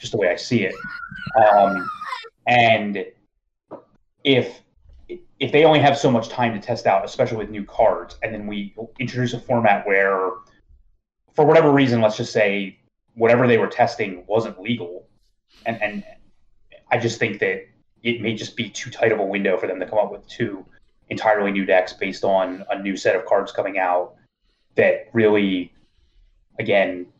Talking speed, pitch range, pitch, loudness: 175 wpm, 100-125 Hz, 110 Hz, -20 LUFS